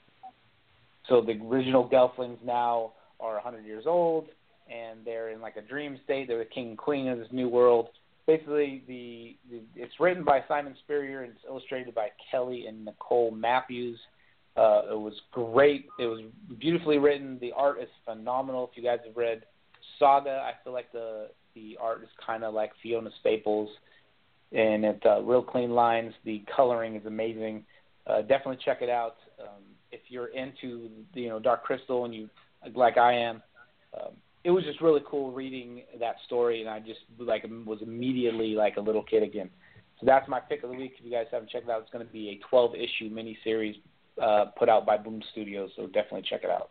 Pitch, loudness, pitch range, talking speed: 120 Hz, -28 LUFS, 110-130 Hz, 195 wpm